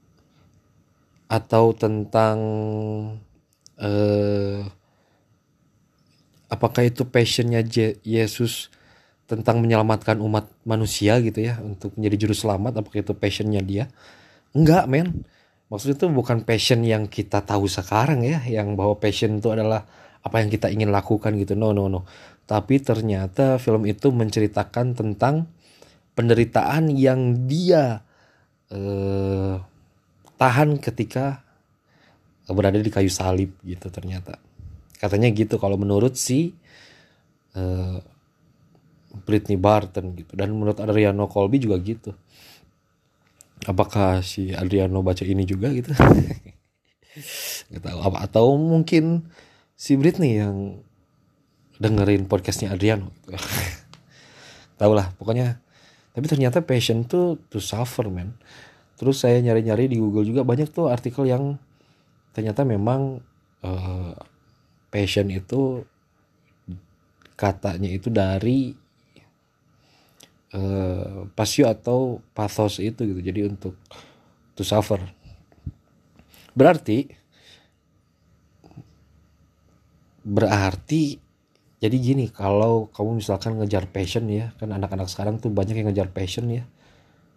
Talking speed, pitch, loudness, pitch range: 110 wpm, 110 Hz, -22 LUFS, 100-125 Hz